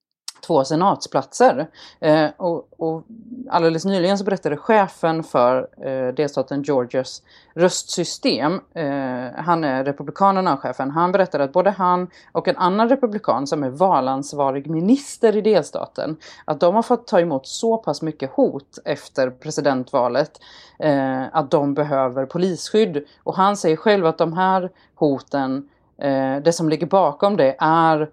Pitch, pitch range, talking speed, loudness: 160 Hz, 140-190 Hz, 145 wpm, -20 LUFS